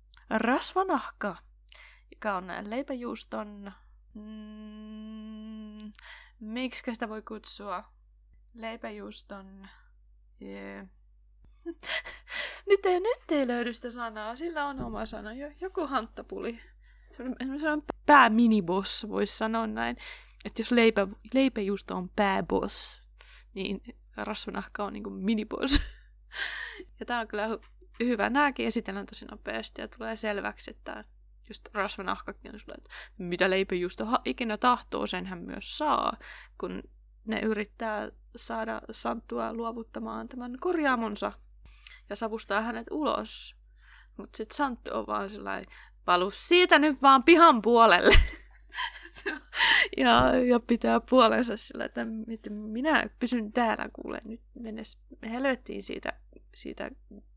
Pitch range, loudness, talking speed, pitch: 205-255 Hz, -28 LUFS, 110 wpm, 225 Hz